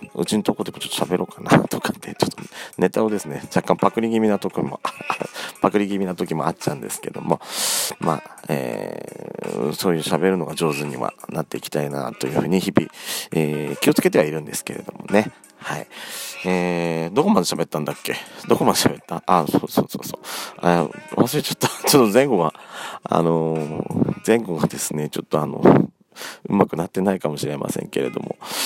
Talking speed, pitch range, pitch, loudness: 395 characters per minute, 75-95 Hz, 85 Hz, -21 LUFS